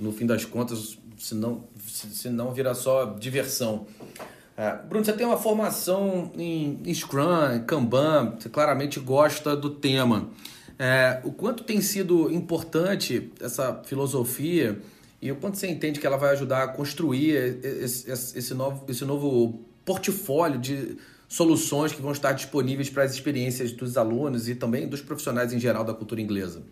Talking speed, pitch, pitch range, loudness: 160 wpm, 135 Hz, 120-155 Hz, -26 LUFS